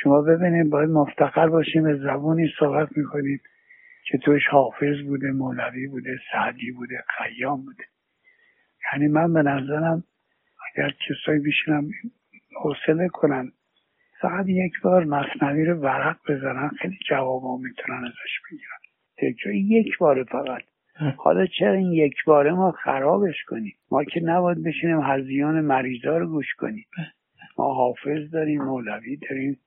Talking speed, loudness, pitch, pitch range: 135 wpm, -23 LUFS, 150 Hz, 140-170 Hz